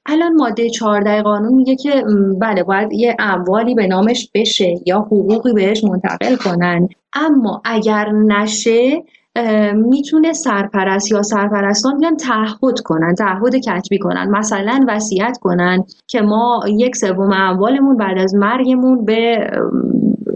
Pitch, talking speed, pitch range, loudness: 215 Hz, 125 wpm, 195-245 Hz, -14 LUFS